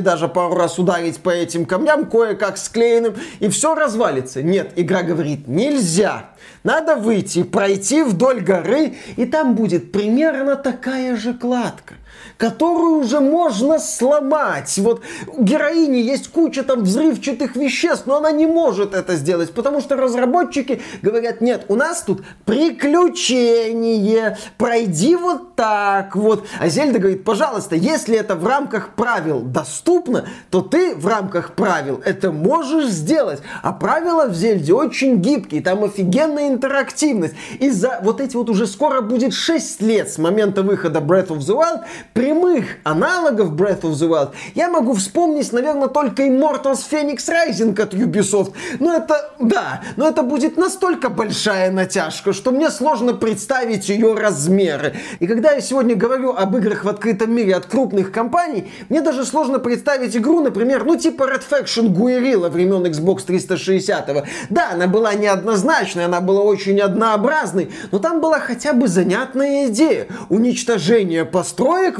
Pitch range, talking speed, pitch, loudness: 195-285 Hz, 150 wpm, 230 Hz, -17 LUFS